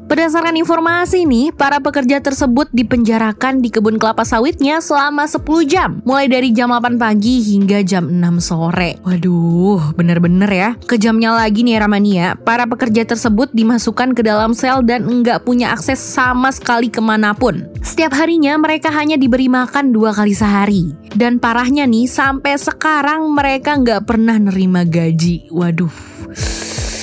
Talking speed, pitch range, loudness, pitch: 140 wpm, 210-280 Hz, -13 LUFS, 240 Hz